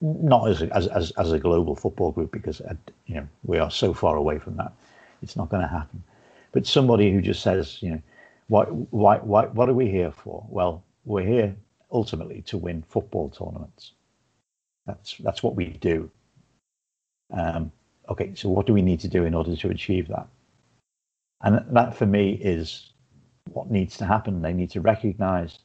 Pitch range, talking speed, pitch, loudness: 90-110 Hz, 185 wpm, 100 Hz, -24 LUFS